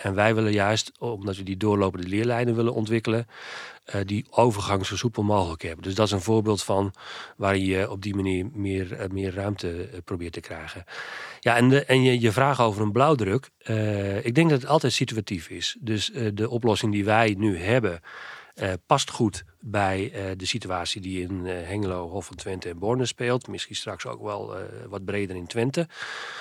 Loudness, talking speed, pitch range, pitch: -25 LUFS, 200 wpm, 95-115 Hz, 105 Hz